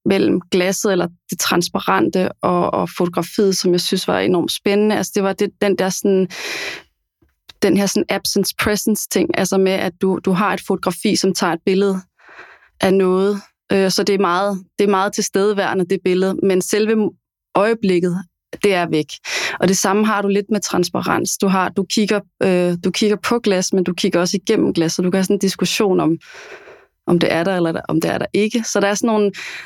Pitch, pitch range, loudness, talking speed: 195 Hz, 185-205 Hz, -17 LUFS, 205 wpm